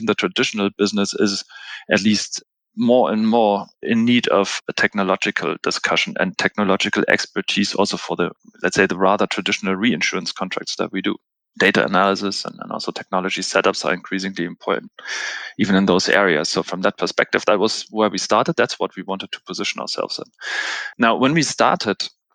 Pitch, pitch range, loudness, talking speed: 100 Hz, 95-110 Hz, -19 LUFS, 175 wpm